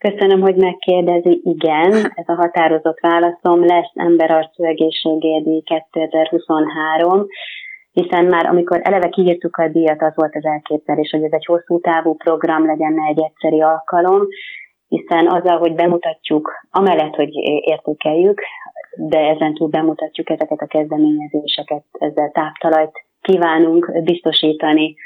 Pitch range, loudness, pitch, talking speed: 155-175 Hz, -15 LUFS, 160 Hz, 120 wpm